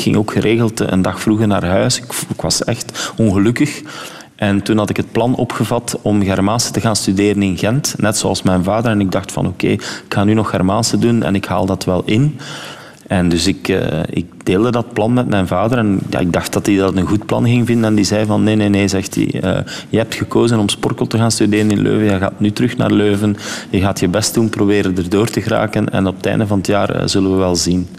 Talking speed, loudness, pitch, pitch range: 255 wpm, -15 LUFS, 105 Hz, 95-115 Hz